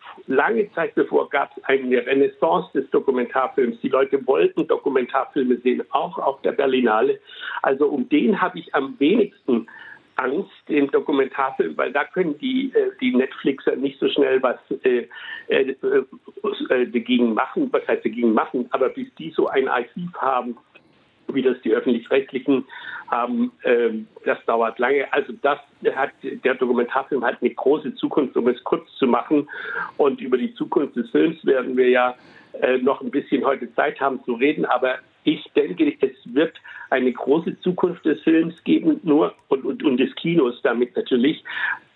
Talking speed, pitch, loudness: 160 wpm, 270 Hz, -21 LUFS